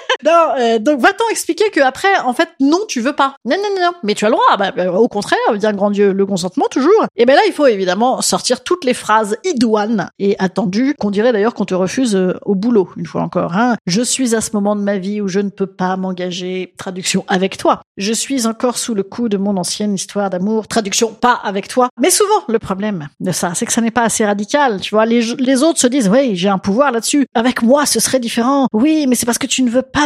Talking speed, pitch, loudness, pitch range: 260 wpm, 230 Hz, -15 LUFS, 200-265 Hz